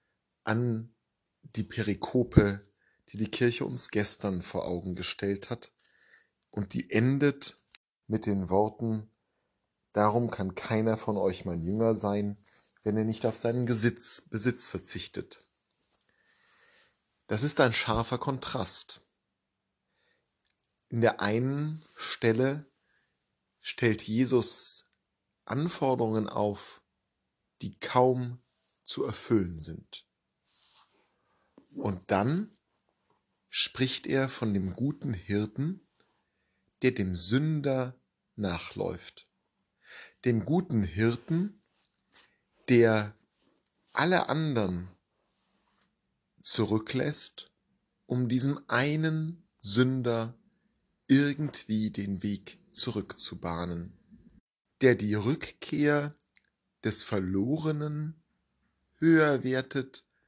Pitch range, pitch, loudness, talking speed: 105-135 Hz, 115 Hz, -28 LUFS, 85 wpm